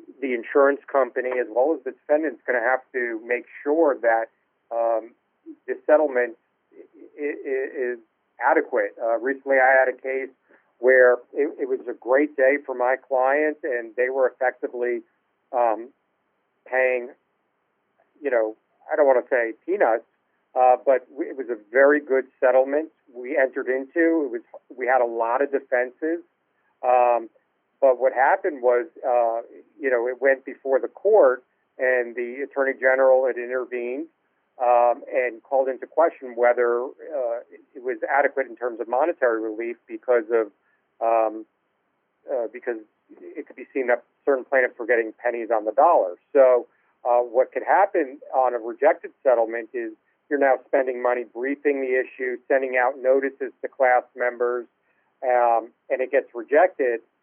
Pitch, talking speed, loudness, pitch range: 130 Hz, 155 wpm, -22 LUFS, 120-155 Hz